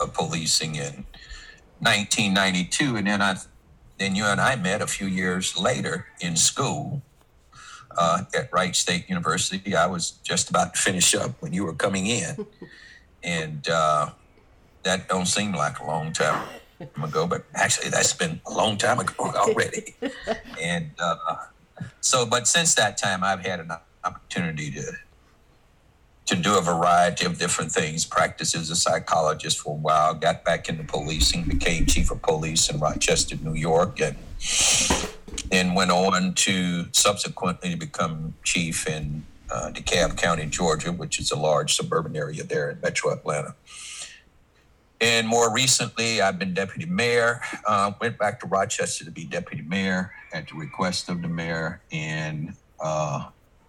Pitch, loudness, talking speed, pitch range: 95 Hz, -23 LUFS, 155 wpm, 85-110 Hz